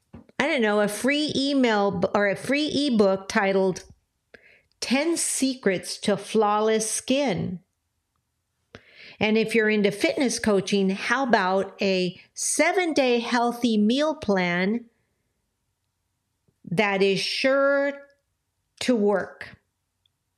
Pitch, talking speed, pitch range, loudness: 210 Hz, 105 wpm, 190-250 Hz, -23 LUFS